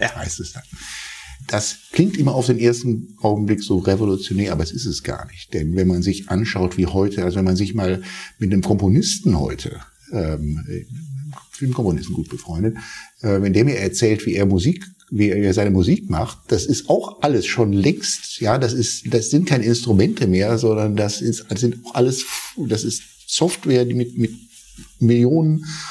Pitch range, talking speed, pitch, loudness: 95-125 Hz, 190 wpm, 110 Hz, -19 LUFS